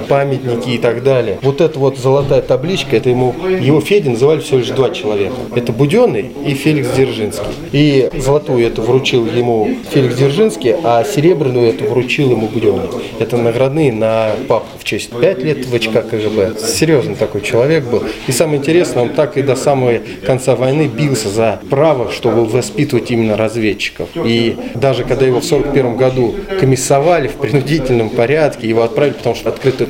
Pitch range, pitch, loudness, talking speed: 120-140 Hz, 130 Hz, -13 LUFS, 170 wpm